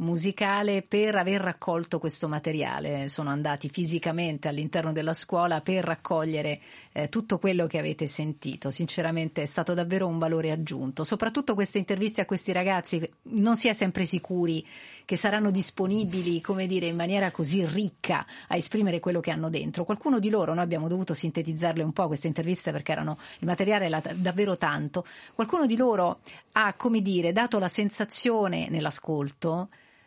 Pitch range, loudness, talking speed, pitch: 160-200 Hz, -28 LUFS, 160 wpm, 175 Hz